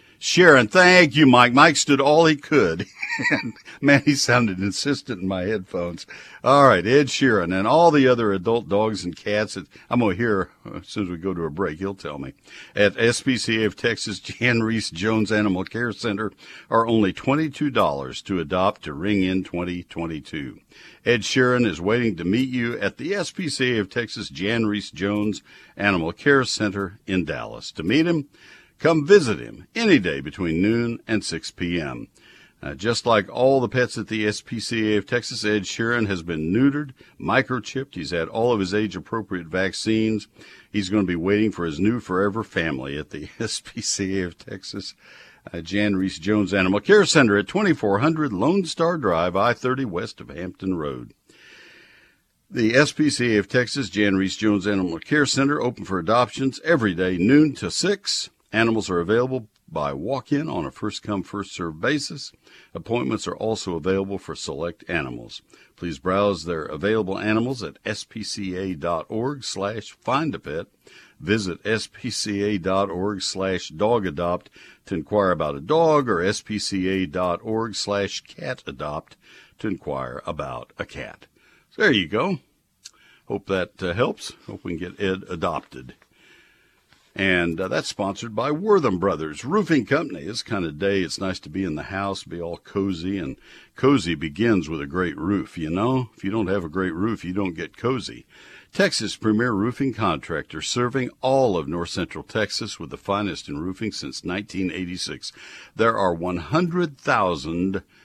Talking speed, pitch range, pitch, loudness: 160 wpm, 95-125 Hz, 105 Hz, -22 LUFS